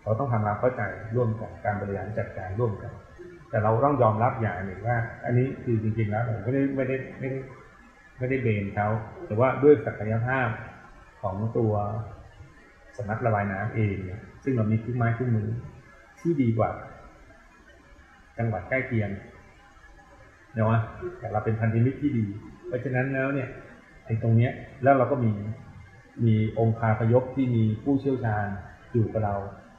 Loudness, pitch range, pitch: -27 LUFS, 105-125 Hz, 115 Hz